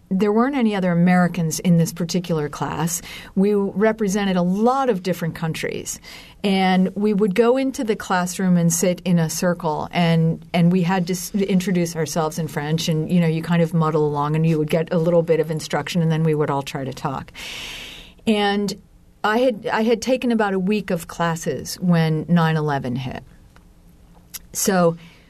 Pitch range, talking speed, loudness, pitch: 160-200 Hz, 185 wpm, -20 LUFS, 175 Hz